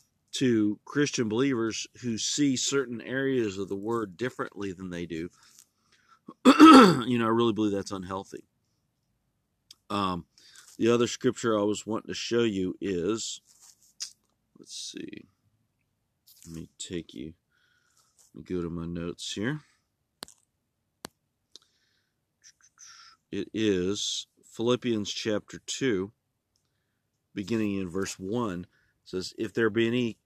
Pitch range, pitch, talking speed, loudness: 100-125 Hz, 110 Hz, 115 wpm, -26 LUFS